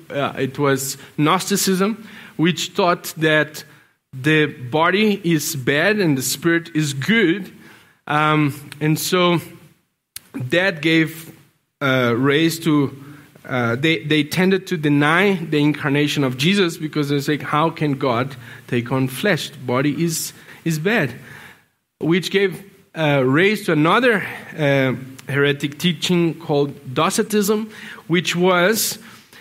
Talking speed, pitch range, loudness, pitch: 120 wpm, 145-180 Hz, -19 LUFS, 155 Hz